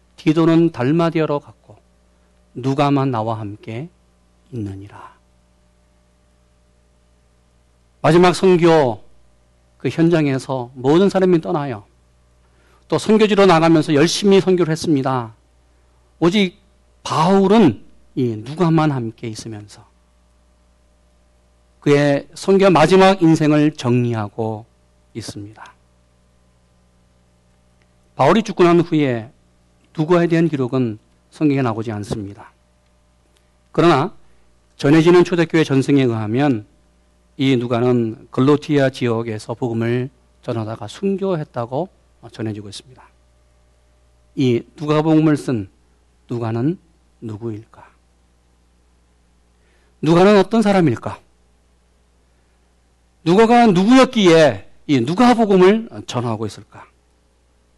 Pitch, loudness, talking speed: 110 Hz, -16 LUFS, 215 characters per minute